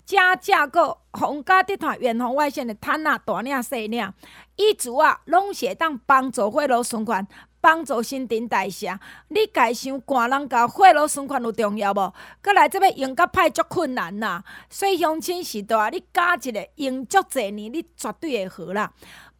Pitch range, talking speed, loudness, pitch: 230-345 Hz, 255 characters per minute, -21 LUFS, 275 Hz